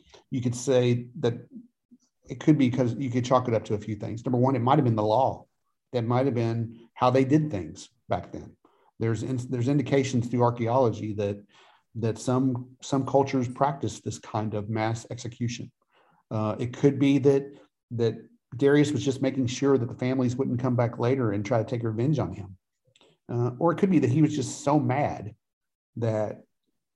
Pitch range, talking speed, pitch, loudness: 115-135 Hz, 200 wpm, 125 Hz, -26 LUFS